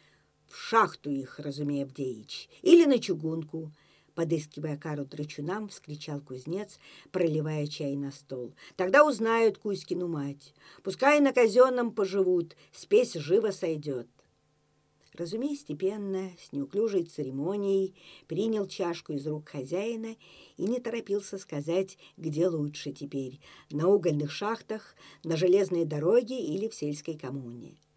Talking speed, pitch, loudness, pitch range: 120 wpm, 175 Hz, -29 LUFS, 150-205 Hz